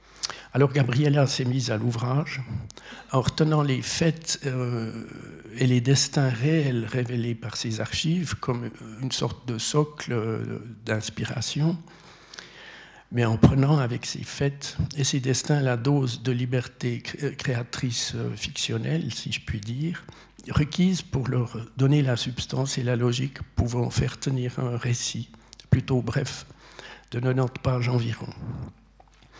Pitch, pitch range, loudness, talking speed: 130 Hz, 120-140 Hz, -26 LUFS, 130 wpm